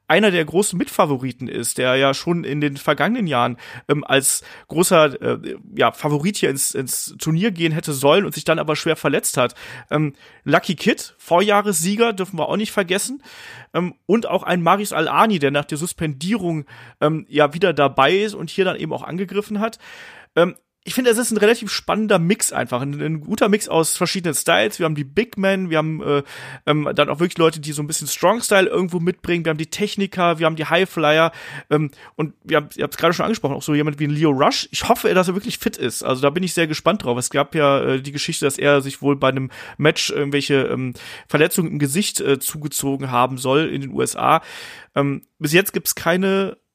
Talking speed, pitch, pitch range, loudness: 215 wpm, 160 Hz, 145-195 Hz, -19 LUFS